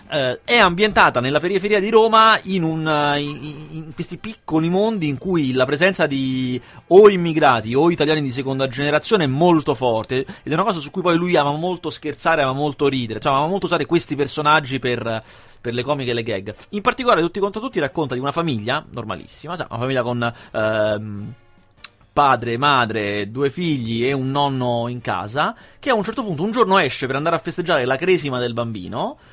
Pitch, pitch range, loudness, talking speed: 145 Hz, 125-175 Hz, -19 LUFS, 195 wpm